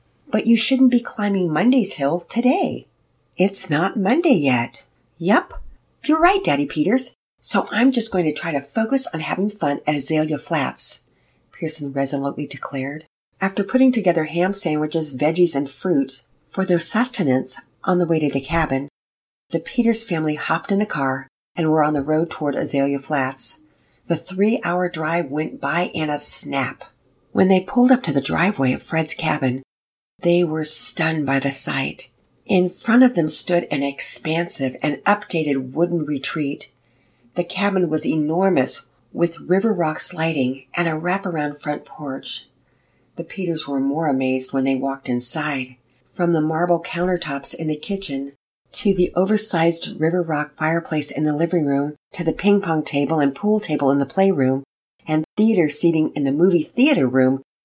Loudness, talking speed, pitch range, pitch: -19 LUFS, 165 wpm, 140-185 Hz, 160 Hz